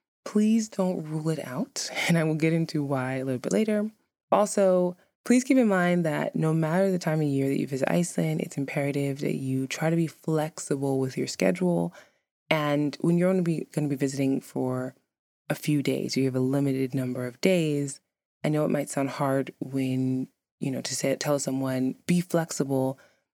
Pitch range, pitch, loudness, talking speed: 135-175 Hz, 145 Hz, -27 LUFS, 195 wpm